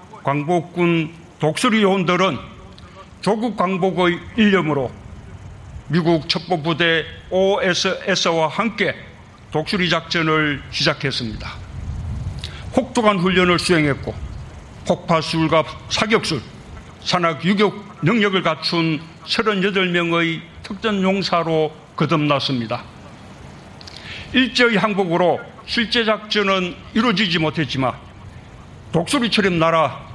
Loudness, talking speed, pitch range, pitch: -19 LUFS, 220 characters per minute, 140-190 Hz, 170 Hz